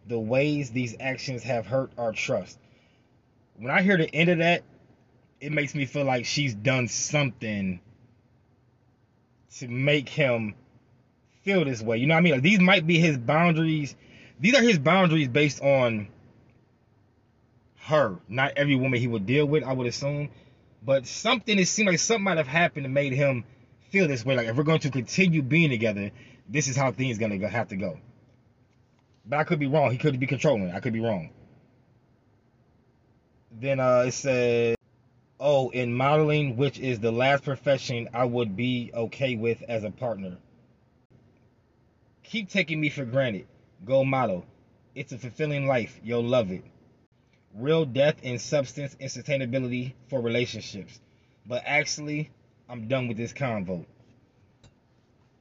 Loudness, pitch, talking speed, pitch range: -25 LUFS, 125 Hz, 165 wpm, 120-145 Hz